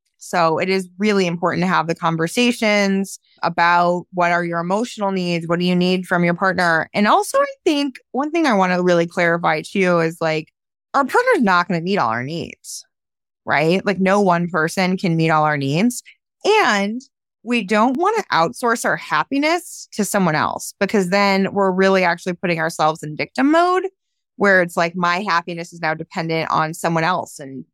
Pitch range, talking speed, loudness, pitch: 170-210 Hz, 195 wpm, -18 LUFS, 185 Hz